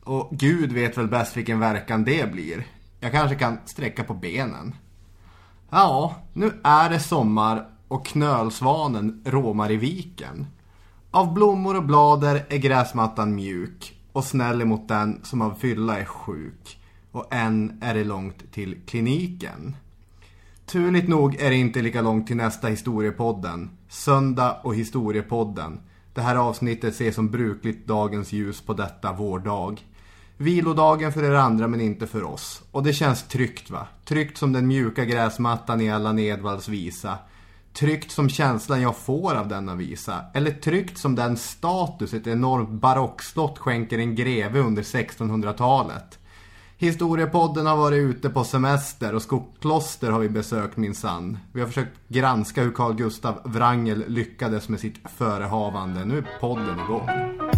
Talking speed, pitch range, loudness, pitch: 150 wpm, 105-135 Hz, -23 LUFS, 115 Hz